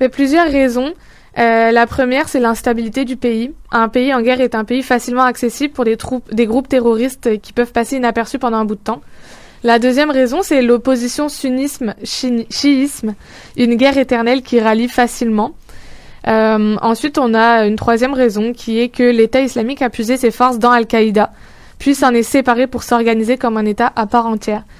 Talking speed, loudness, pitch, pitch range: 185 wpm, -14 LUFS, 245 Hz, 230-260 Hz